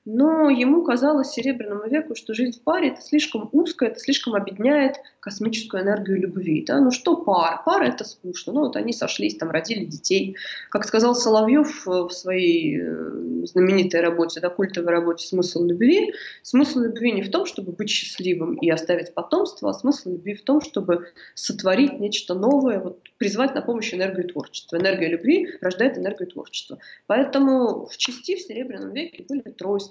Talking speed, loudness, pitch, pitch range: 165 wpm, -22 LUFS, 220 Hz, 185-275 Hz